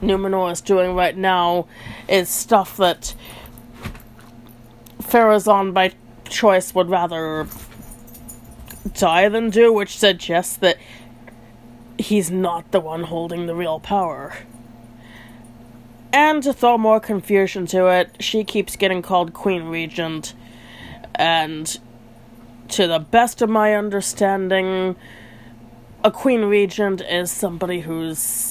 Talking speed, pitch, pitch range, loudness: 110 wpm, 175 Hz, 120-195 Hz, -18 LUFS